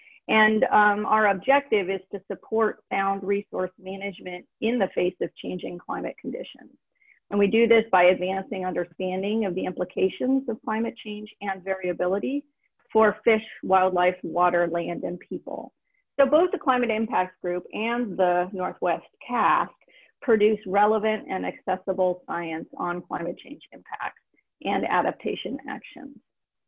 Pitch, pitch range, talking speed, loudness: 200 Hz, 185-220 Hz, 135 wpm, -25 LUFS